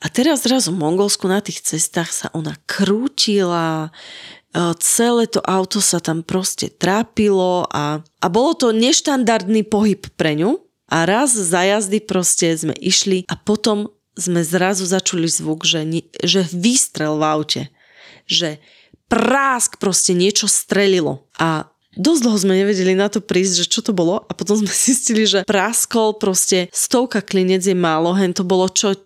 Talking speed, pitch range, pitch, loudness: 155 wpm, 175-215 Hz, 190 Hz, -17 LUFS